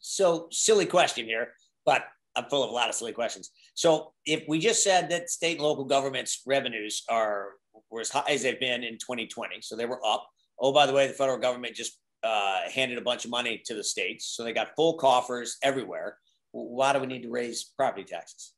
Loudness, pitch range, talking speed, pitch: -27 LUFS, 120-155 Hz, 220 wpm, 130 Hz